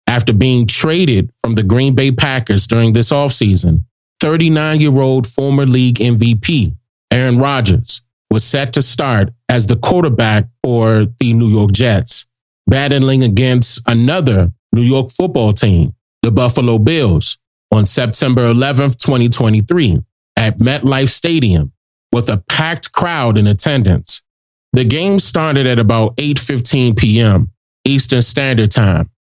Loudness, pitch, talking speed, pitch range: -12 LUFS, 120 Hz, 125 wpm, 110-135 Hz